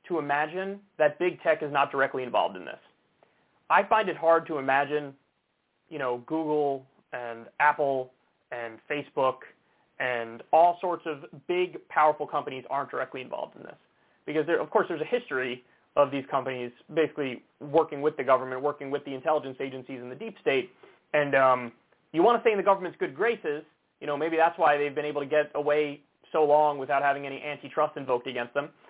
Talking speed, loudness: 185 wpm, -27 LUFS